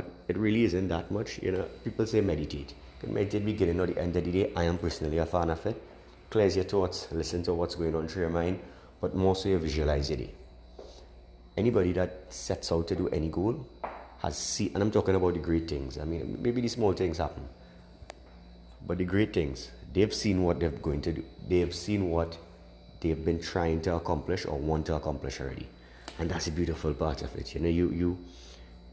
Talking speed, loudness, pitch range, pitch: 220 wpm, -30 LUFS, 75-90 Hz, 85 Hz